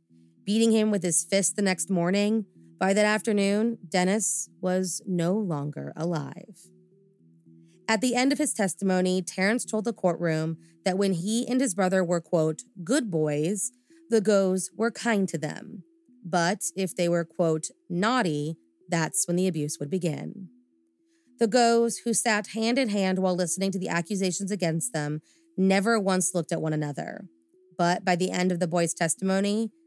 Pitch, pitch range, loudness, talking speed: 190 Hz, 170-215 Hz, -26 LUFS, 165 wpm